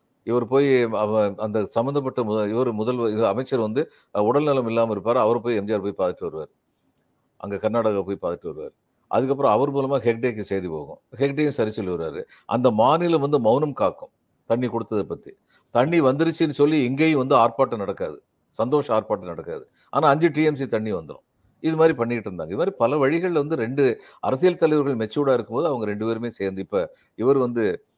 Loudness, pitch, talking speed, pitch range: -22 LUFS, 125 Hz, 165 wpm, 110-145 Hz